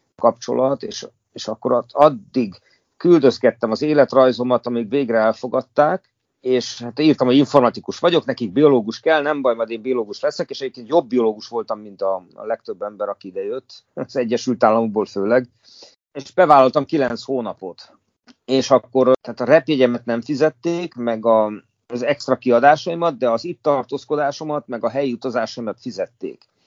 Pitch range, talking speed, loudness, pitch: 120-150 Hz, 150 wpm, -19 LUFS, 130 Hz